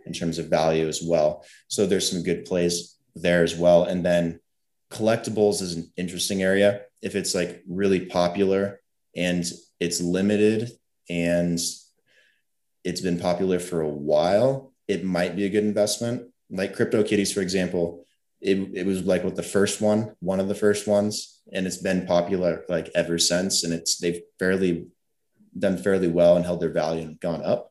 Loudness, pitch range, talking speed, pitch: -24 LUFS, 85-100 Hz, 175 wpm, 90 Hz